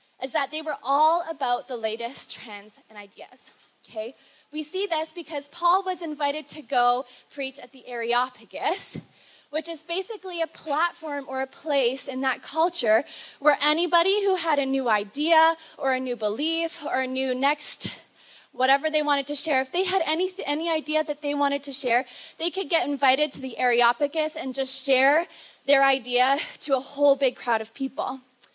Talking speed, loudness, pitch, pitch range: 180 wpm, -24 LUFS, 285 Hz, 260-320 Hz